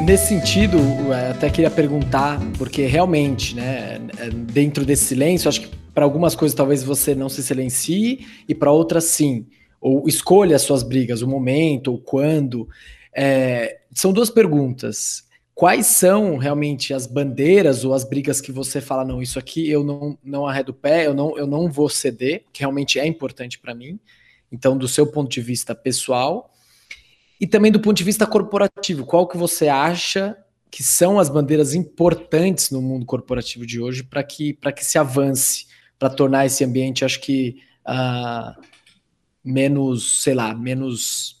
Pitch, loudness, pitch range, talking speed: 140 Hz, -19 LUFS, 130-155 Hz, 165 wpm